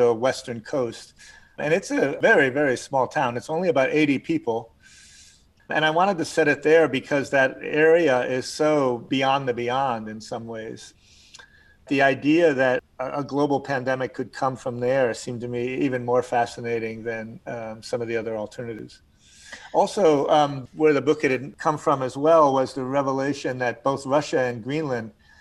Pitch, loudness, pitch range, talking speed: 130 Hz, -23 LUFS, 120-150 Hz, 175 wpm